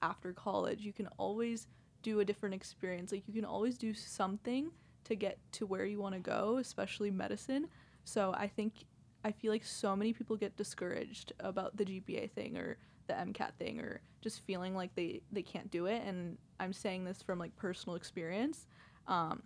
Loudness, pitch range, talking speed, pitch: -40 LUFS, 190-220 Hz, 190 wpm, 205 Hz